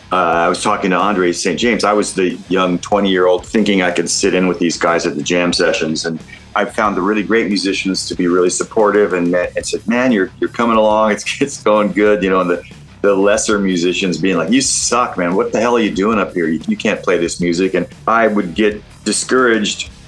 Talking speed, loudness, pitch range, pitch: 240 wpm, -15 LUFS, 90-105 Hz, 95 Hz